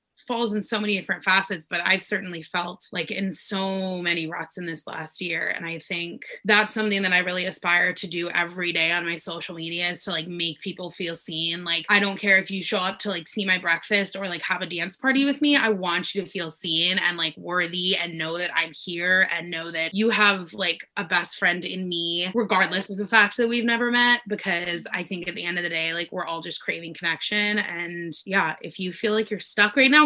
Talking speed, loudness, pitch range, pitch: 245 wpm, -23 LUFS, 170-205 Hz, 180 Hz